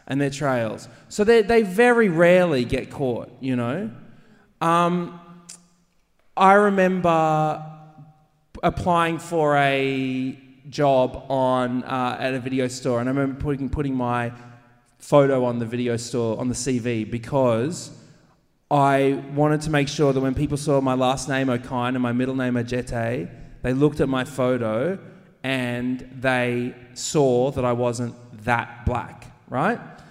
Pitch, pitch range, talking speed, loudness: 130 Hz, 125-155 Hz, 145 wpm, -22 LUFS